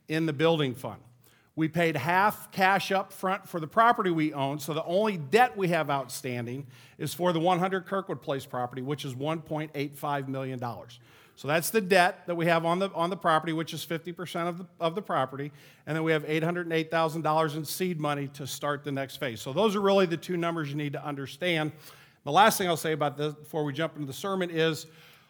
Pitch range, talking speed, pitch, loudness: 145-175 Hz, 225 wpm, 160 Hz, -28 LUFS